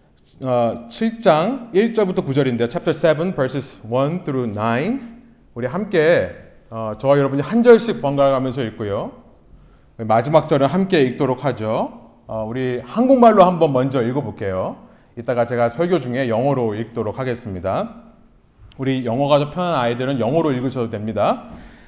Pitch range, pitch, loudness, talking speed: 120-170 Hz, 135 Hz, -19 LUFS, 335 characters per minute